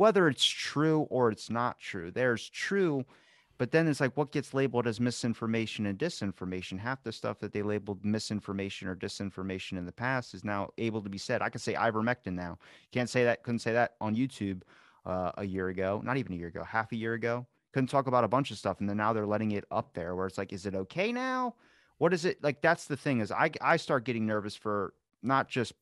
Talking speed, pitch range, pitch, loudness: 235 wpm, 100-135 Hz, 115 Hz, -32 LUFS